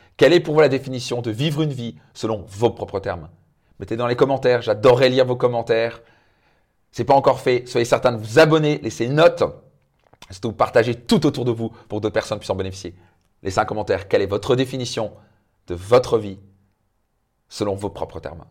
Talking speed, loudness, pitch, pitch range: 200 wpm, -20 LUFS, 115 Hz, 105-130 Hz